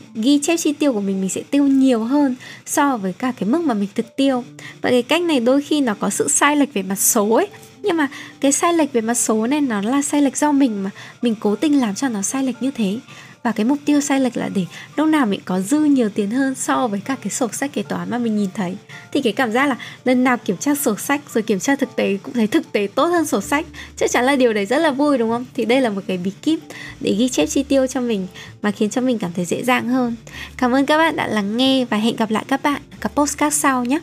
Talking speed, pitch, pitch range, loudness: 290 wpm, 255 Hz, 215-280 Hz, -19 LUFS